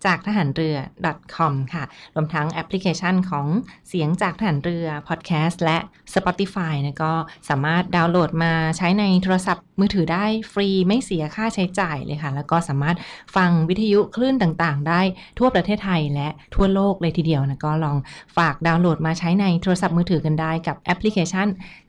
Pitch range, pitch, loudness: 160-190 Hz, 170 Hz, -21 LUFS